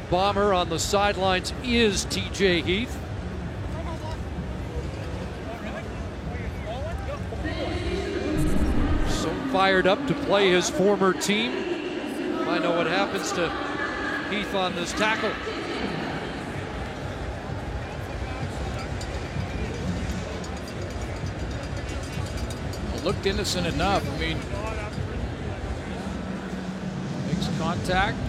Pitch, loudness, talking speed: 175 Hz, -27 LUFS, 70 wpm